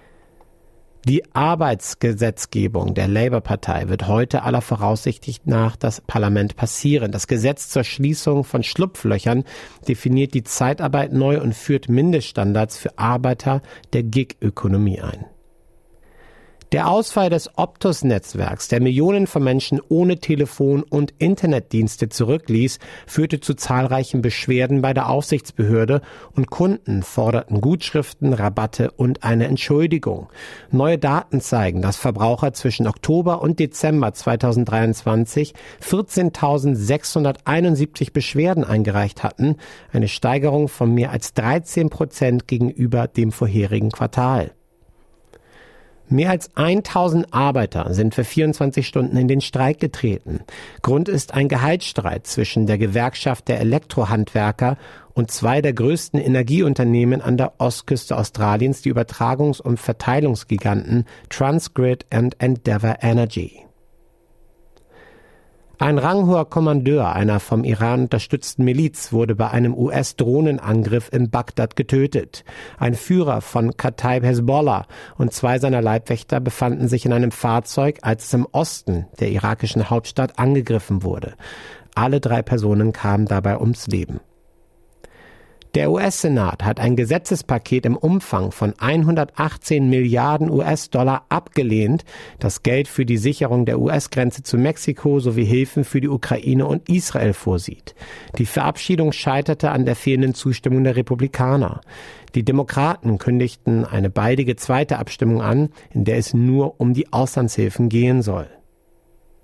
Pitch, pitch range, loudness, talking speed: 125 Hz, 115-145 Hz, -19 LUFS, 120 wpm